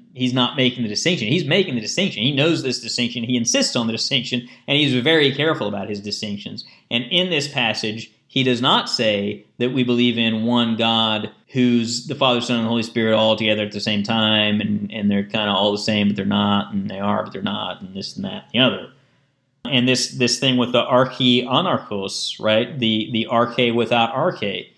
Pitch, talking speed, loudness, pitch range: 120 Hz, 220 wpm, -19 LUFS, 110-130 Hz